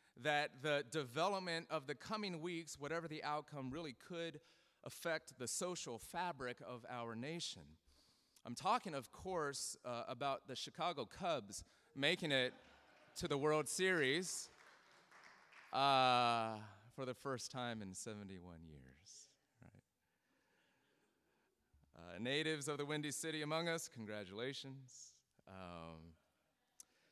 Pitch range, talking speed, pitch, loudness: 110-155 Hz, 115 wpm, 135 Hz, -42 LUFS